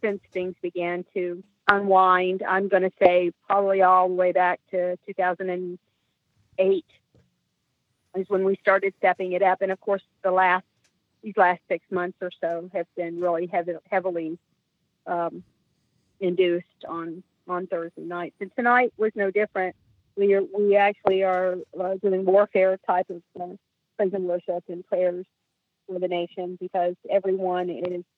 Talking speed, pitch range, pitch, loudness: 155 wpm, 175-195 Hz, 185 Hz, -24 LUFS